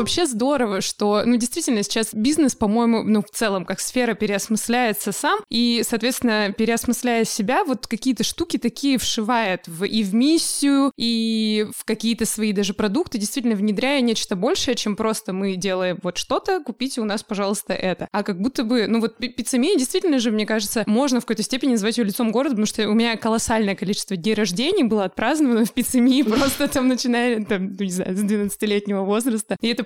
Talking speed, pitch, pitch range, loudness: 185 wpm, 225 Hz, 210-250 Hz, -21 LUFS